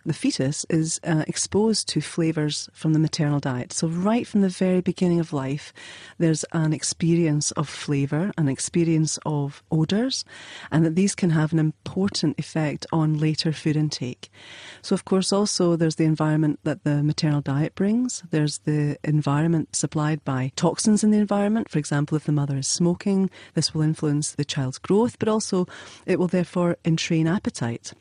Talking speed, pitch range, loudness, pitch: 175 wpm, 150-180 Hz, -23 LUFS, 160 Hz